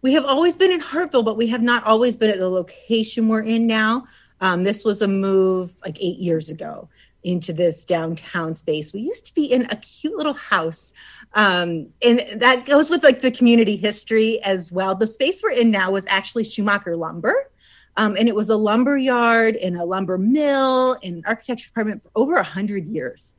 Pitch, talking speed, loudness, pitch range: 220 Hz, 205 wpm, -19 LUFS, 190-250 Hz